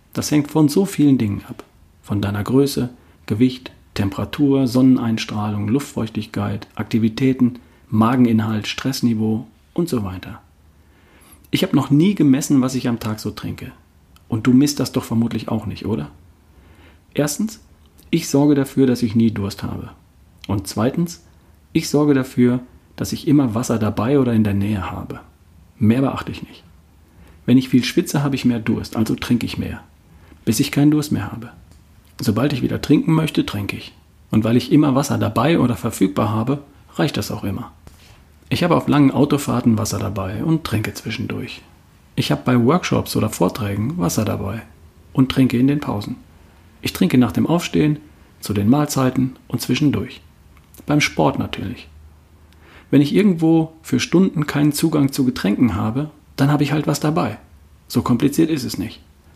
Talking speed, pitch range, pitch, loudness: 165 wpm, 95-135 Hz, 115 Hz, -19 LUFS